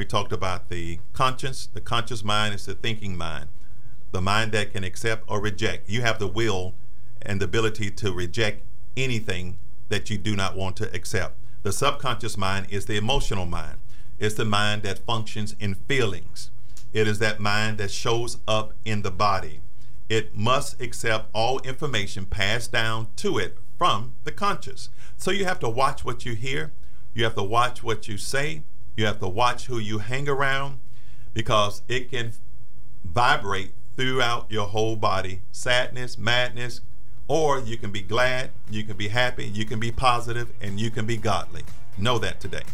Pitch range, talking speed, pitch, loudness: 105-120 Hz, 175 wpm, 115 Hz, -26 LUFS